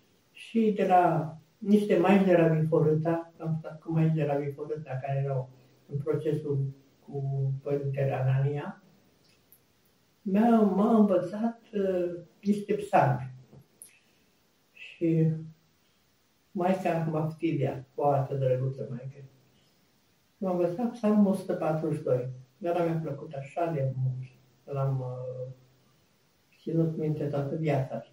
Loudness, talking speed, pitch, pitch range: -28 LUFS, 110 wpm, 155 Hz, 135-175 Hz